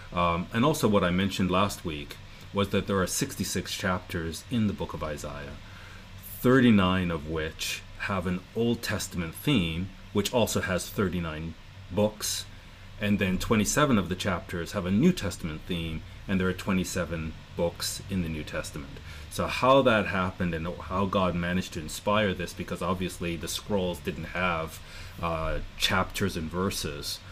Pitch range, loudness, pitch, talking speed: 85-100 Hz, -28 LUFS, 95 Hz, 160 wpm